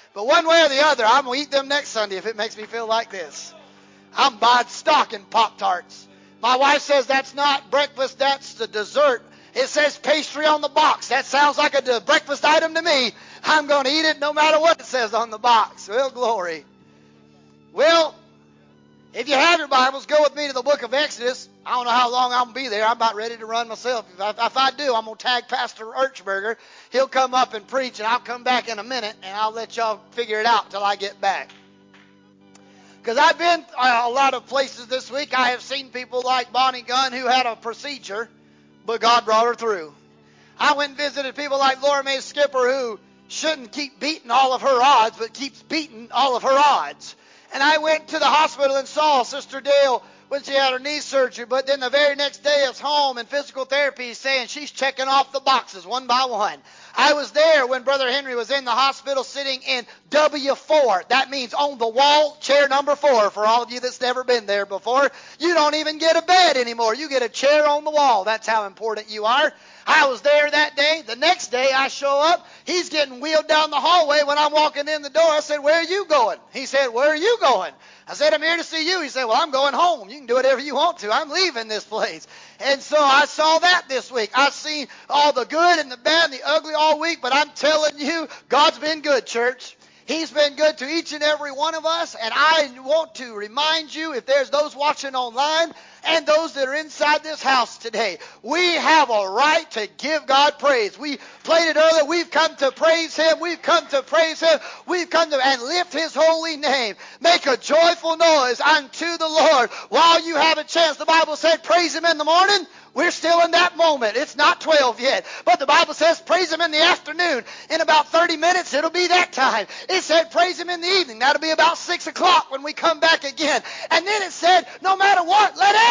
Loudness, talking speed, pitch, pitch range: -19 LUFS, 230 wpm, 280 Hz, 250-310 Hz